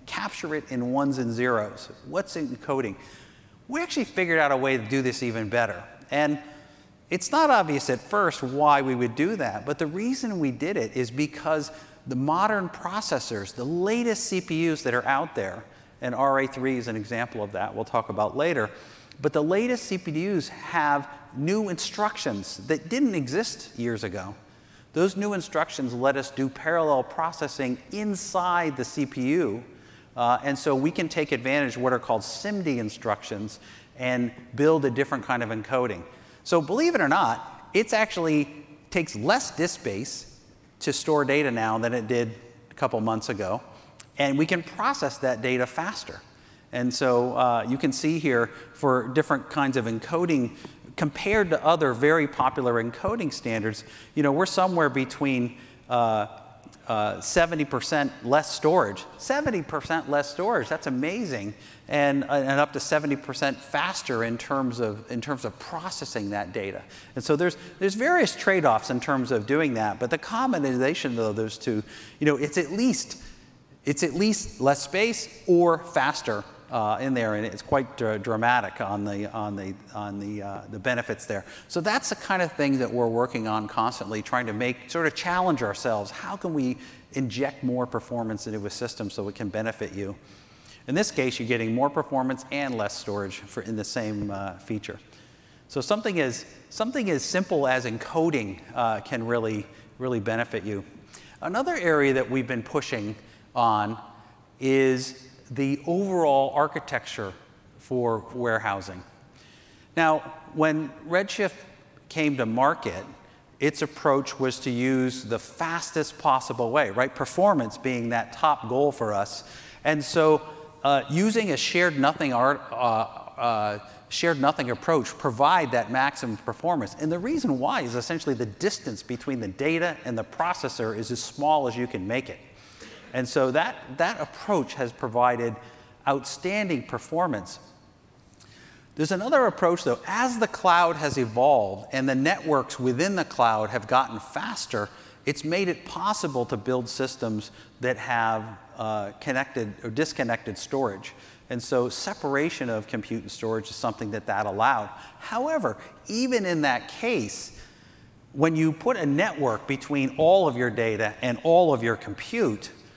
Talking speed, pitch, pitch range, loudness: 160 wpm, 130 Hz, 115-155 Hz, -26 LUFS